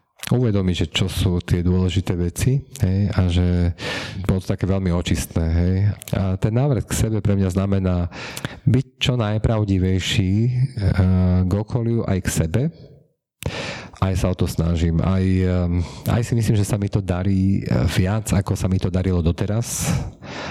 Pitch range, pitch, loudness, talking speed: 90-115 Hz, 95 Hz, -21 LUFS, 155 wpm